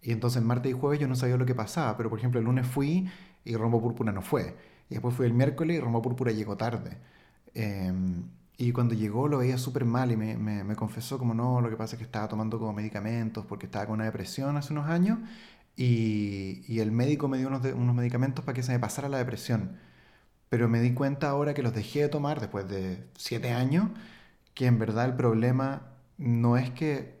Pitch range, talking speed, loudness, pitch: 110-135 Hz, 225 wpm, -29 LUFS, 120 Hz